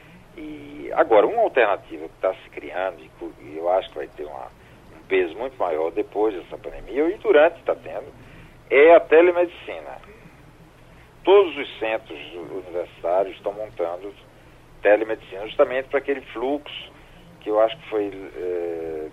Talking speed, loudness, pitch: 145 wpm, -21 LUFS, 140 Hz